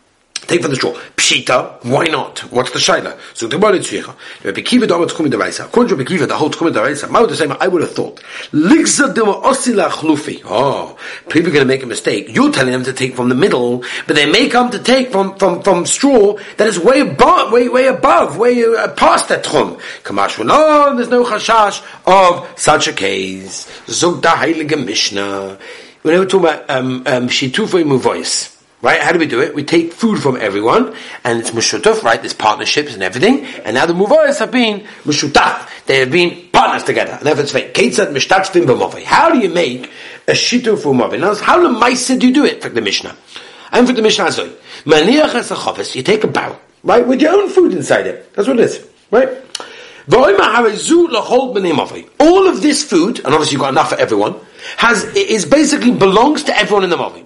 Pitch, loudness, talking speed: 225 Hz, -12 LUFS, 185 wpm